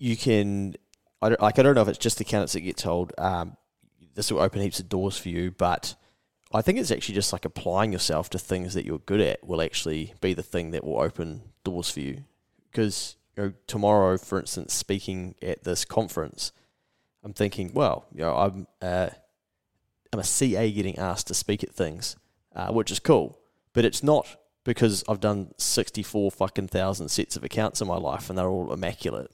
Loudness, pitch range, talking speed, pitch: -27 LUFS, 90-110 Hz, 210 wpm, 100 Hz